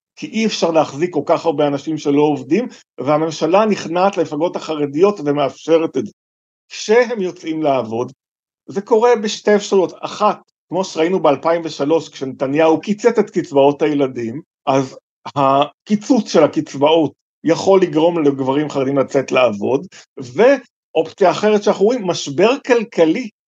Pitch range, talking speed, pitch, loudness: 145-200 Hz, 125 wpm, 160 Hz, -16 LUFS